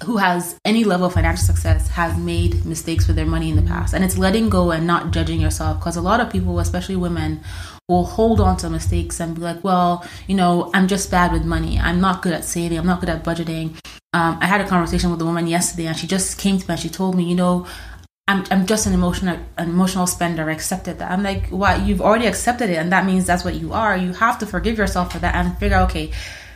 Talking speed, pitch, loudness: 260 wpm, 170 Hz, -19 LUFS